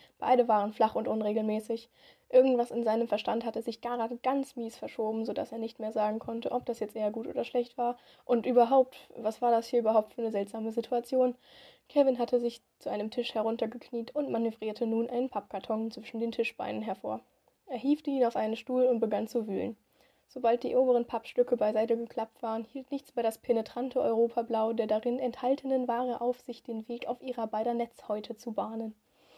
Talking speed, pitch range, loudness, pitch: 190 wpm, 225-245 Hz, -31 LUFS, 235 Hz